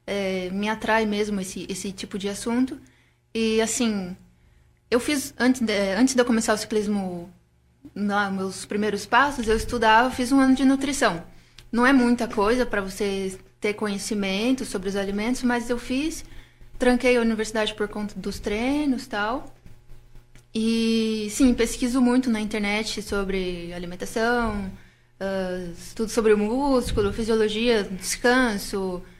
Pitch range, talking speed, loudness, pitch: 200-240 Hz, 140 wpm, -24 LUFS, 220 Hz